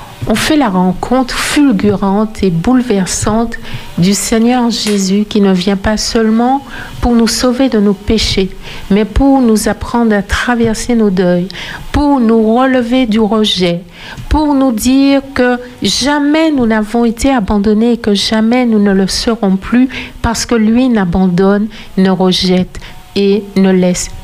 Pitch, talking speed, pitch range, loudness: 220 Hz, 150 wpm, 195-245 Hz, -11 LUFS